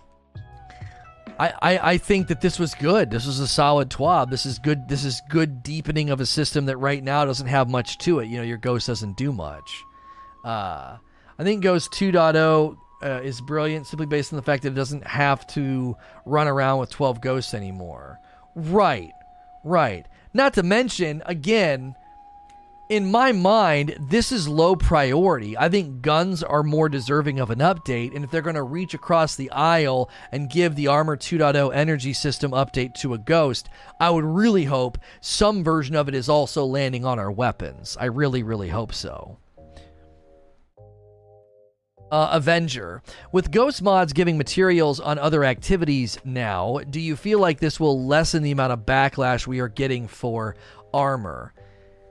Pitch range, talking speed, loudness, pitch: 125-165 Hz, 170 wpm, -22 LUFS, 145 Hz